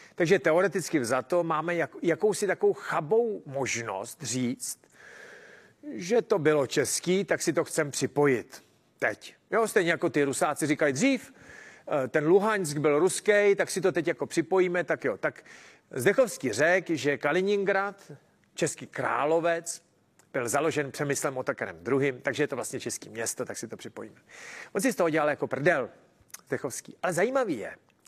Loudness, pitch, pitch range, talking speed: -27 LUFS, 170 Hz, 145-200 Hz, 155 wpm